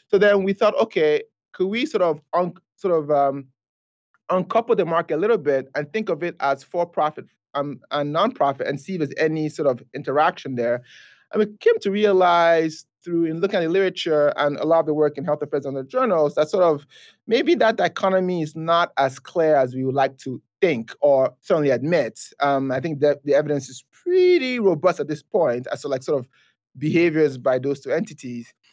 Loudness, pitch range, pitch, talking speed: -21 LUFS, 140-190 Hz, 155 Hz, 210 wpm